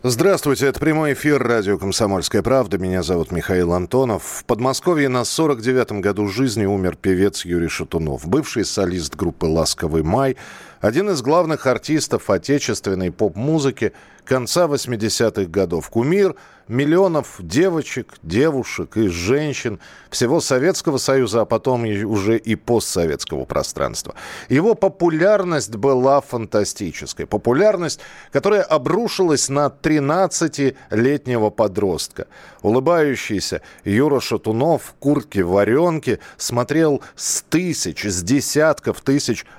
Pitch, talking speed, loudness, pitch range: 130 Hz, 110 wpm, -19 LUFS, 105-150 Hz